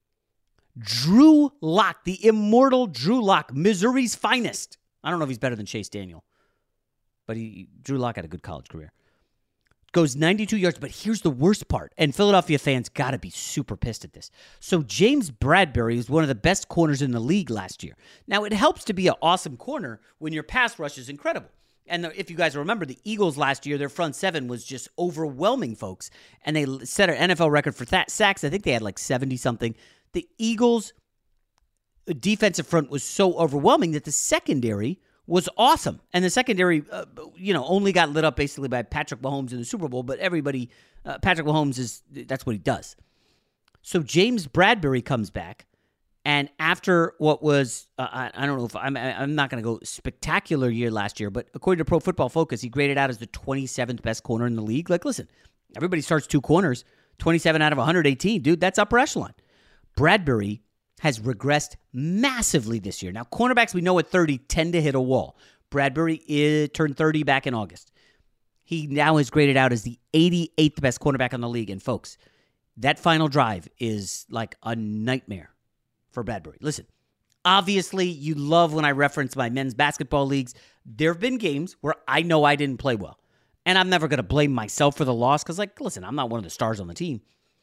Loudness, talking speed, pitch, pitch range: -23 LUFS, 200 wpm, 145 Hz, 125-175 Hz